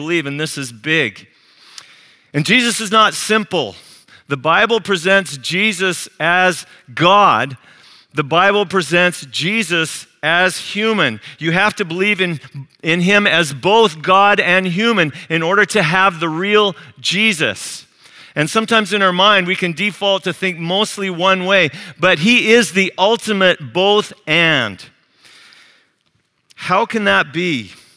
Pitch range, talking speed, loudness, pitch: 165-205 Hz, 140 wpm, -14 LUFS, 185 Hz